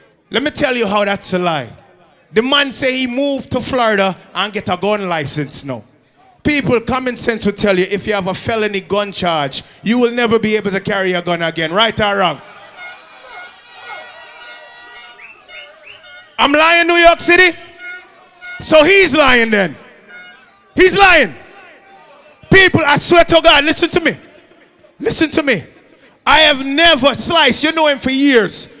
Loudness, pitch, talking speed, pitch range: -12 LUFS, 230 Hz, 165 wpm, 195-305 Hz